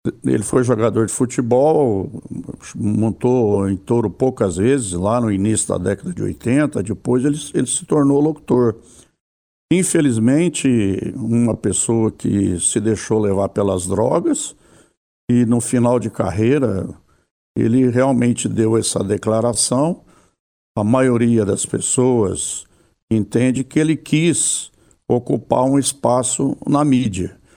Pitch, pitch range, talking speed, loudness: 120 Hz, 105-130 Hz, 120 wpm, -17 LUFS